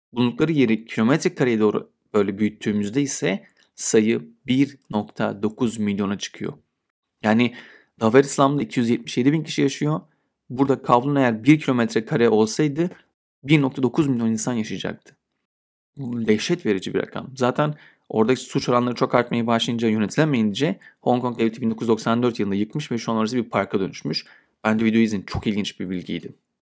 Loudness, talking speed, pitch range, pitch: -22 LUFS, 145 wpm, 110-135 Hz, 120 Hz